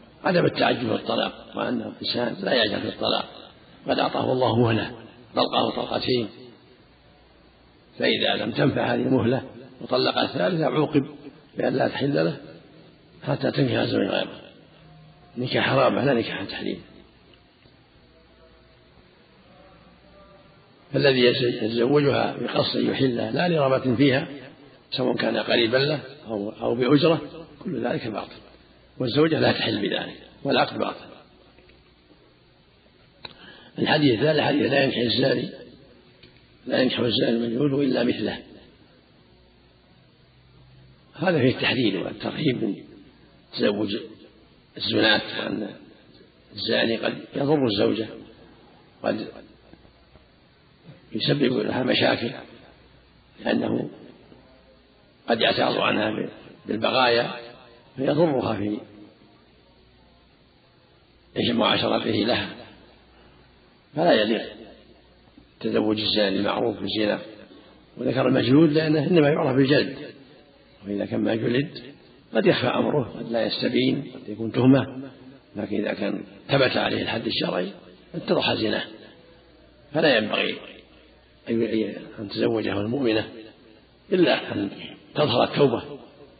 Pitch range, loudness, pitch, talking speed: 100-135 Hz, -23 LUFS, 120 Hz, 95 wpm